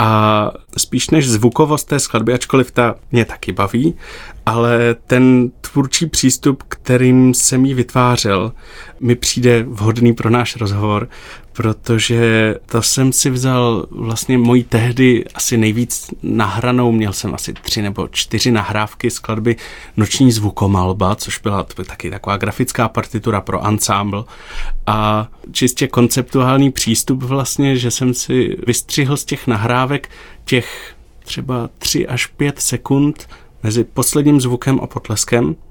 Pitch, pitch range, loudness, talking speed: 120 Hz, 110-130 Hz, -15 LUFS, 130 wpm